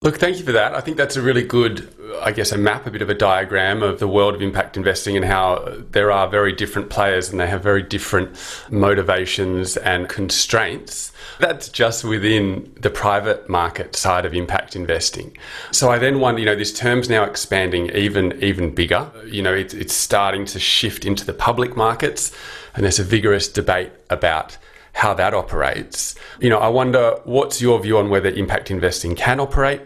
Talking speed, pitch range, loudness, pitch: 195 wpm, 95-115 Hz, -18 LUFS, 100 Hz